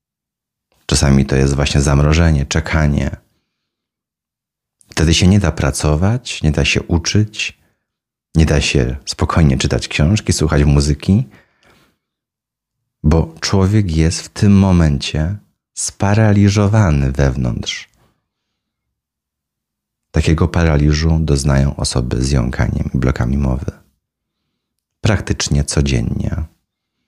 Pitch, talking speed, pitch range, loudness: 75 Hz, 95 wpm, 70-90 Hz, -15 LUFS